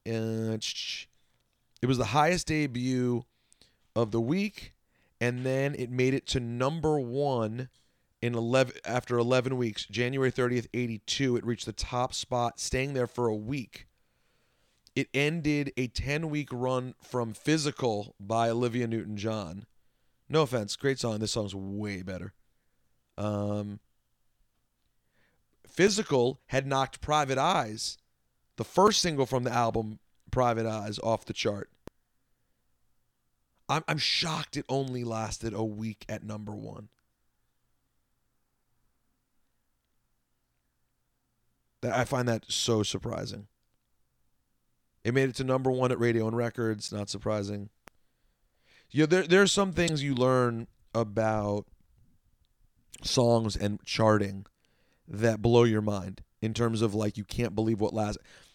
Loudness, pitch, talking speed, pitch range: -29 LUFS, 115 Hz, 130 wpm, 105-130 Hz